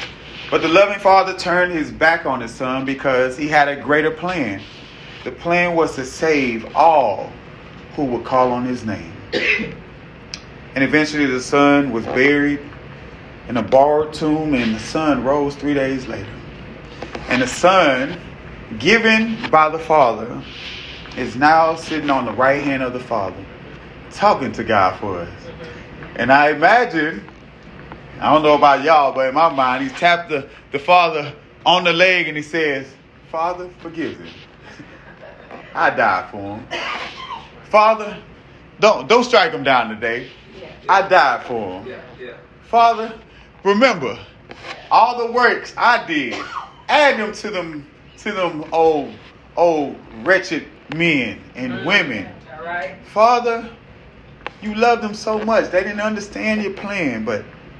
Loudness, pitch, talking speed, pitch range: -17 LUFS, 155 Hz, 145 wpm, 135-190 Hz